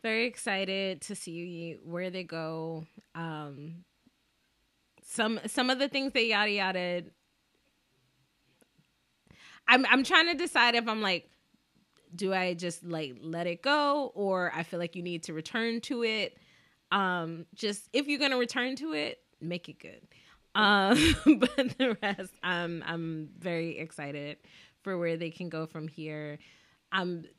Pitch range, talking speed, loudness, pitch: 165-230 Hz, 150 wpm, -30 LUFS, 185 Hz